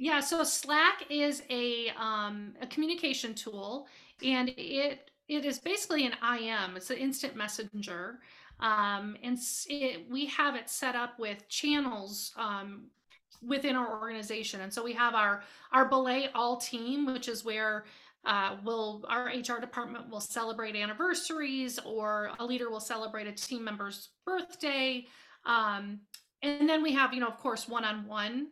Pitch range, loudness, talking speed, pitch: 215-275 Hz, -32 LUFS, 160 wpm, 240 Hz